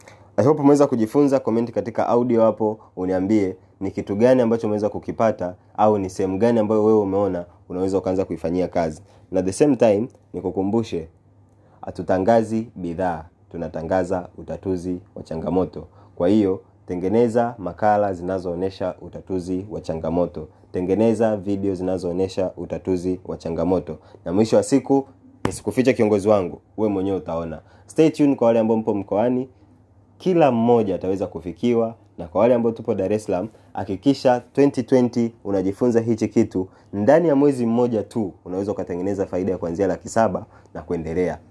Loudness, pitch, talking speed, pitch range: -21 LUFS, 100 Hz, 135 wpm, 95-115 Hz